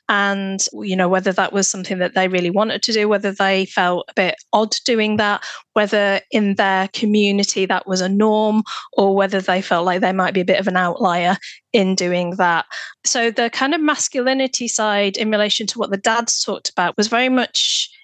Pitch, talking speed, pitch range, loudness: 200 Hz, 205 wpm, 190-220 Hz, -18 LUFS